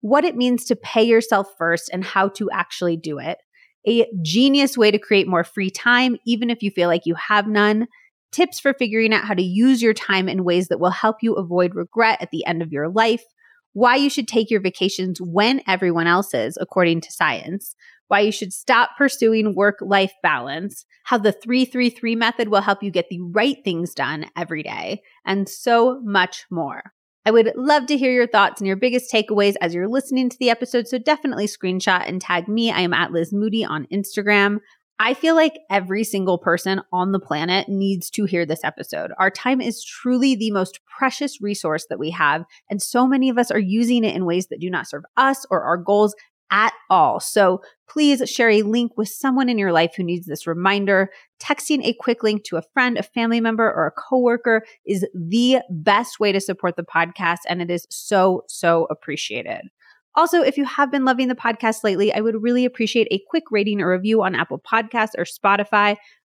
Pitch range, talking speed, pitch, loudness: 185-240 Hz, 210 wpm, 210 Hz, -19 LUFS